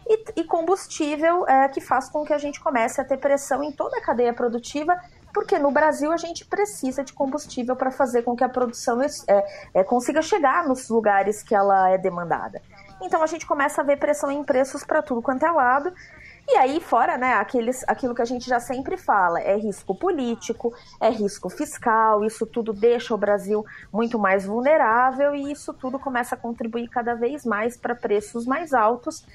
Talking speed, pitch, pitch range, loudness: 195 wpm, 255 Hz, 230-300 Hz, -23 LUFS